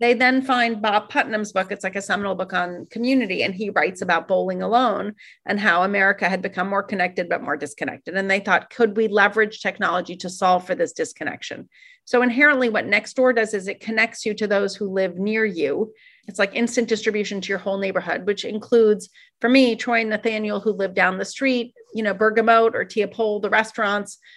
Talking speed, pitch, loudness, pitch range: 205 wpm, 210 Hz, -21 LUFS, 195-230 Hz